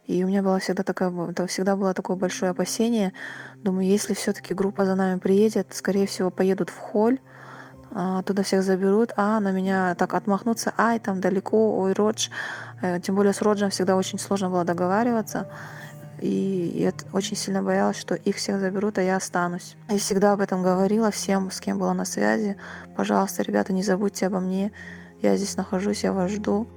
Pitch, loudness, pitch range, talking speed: 190 Hz, -24 LUFS, 185-200 Hz, 180 wpm